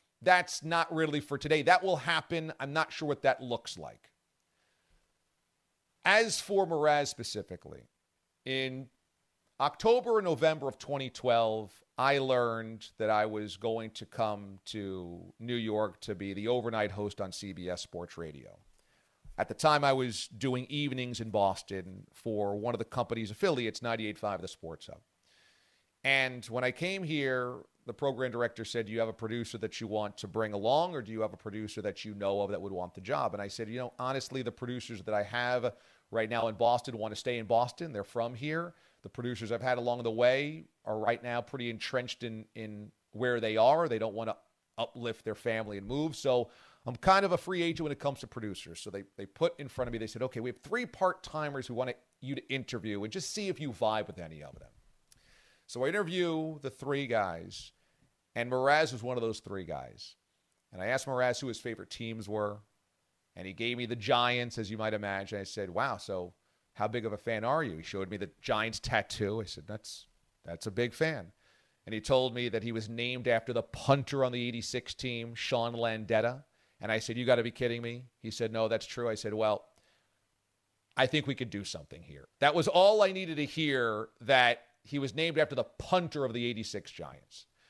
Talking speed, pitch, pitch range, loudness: 210 wpm, 120 Hz, 110-135 Hz, -33 LUFS